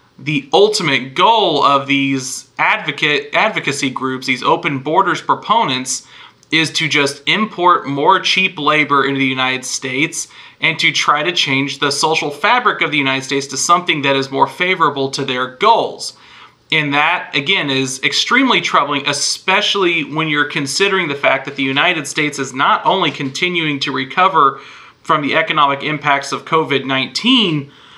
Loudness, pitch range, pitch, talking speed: -14 LUFS, 135-165 Hz, 145 Hz, 155 wpm